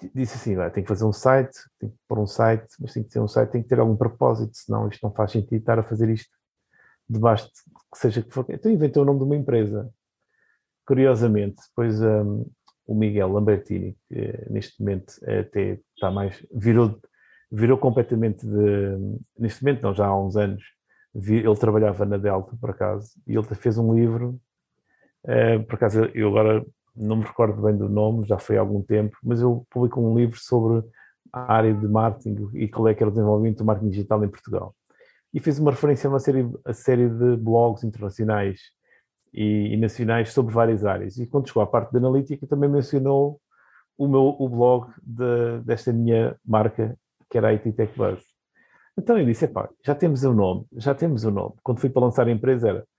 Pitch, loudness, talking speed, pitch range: 115 Hz, -22 LUFS, 205 wpm, 105-125 Hz